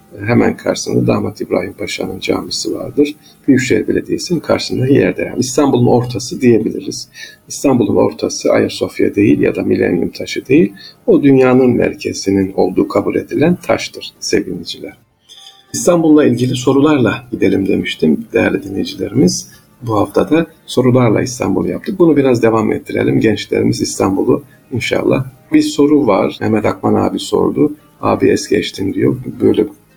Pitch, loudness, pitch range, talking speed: 130 Hz, -14 LUFS, 110-150 Hz, 130 wpm